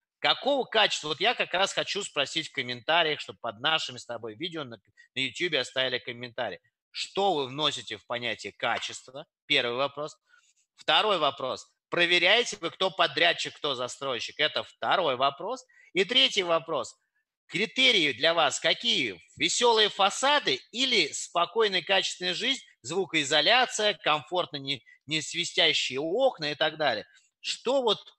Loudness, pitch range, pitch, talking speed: -26 LUFS, 145-215 Hz, 170 Hz, 135 wpm